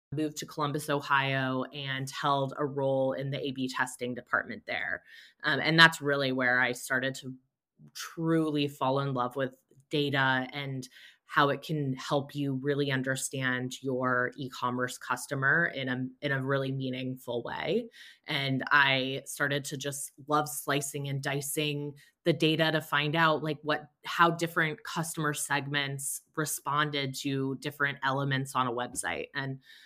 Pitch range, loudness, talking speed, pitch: 130-150 Hz, -30 LUFS, 150 wpm, 140 Hz